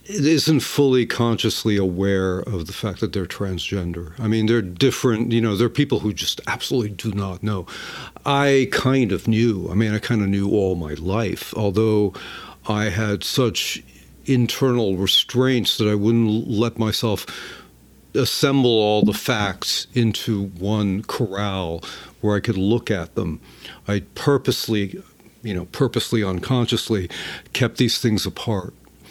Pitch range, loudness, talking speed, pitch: 100-120 Hz, -21 LUFS, 150 wpm, 110 Hz